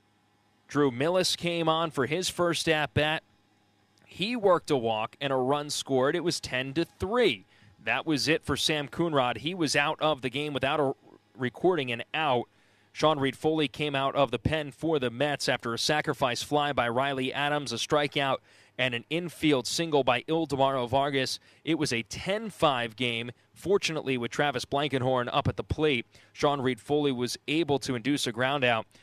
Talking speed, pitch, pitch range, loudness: 180 wpm, 140 Hz, 125-155 Hz, -28 LUFS